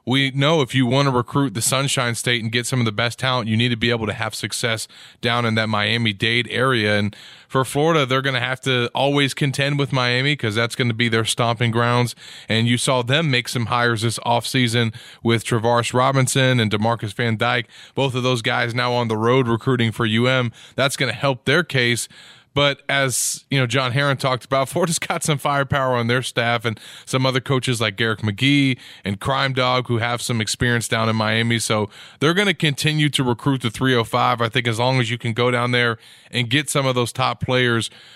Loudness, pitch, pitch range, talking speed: -19 LUFS, 125 Hz, 115-135 Hz, 225 wpm